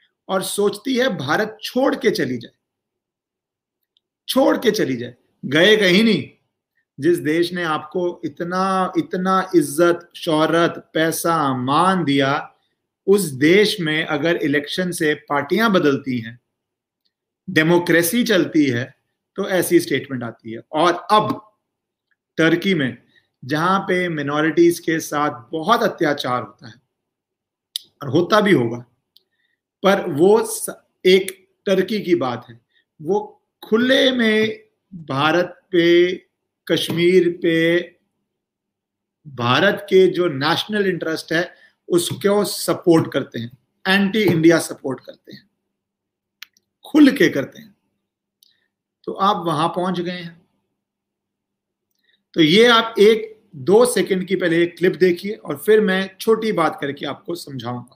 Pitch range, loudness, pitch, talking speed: 155-205 Hz, -18 LUFS, 175 Hz, 120 wpm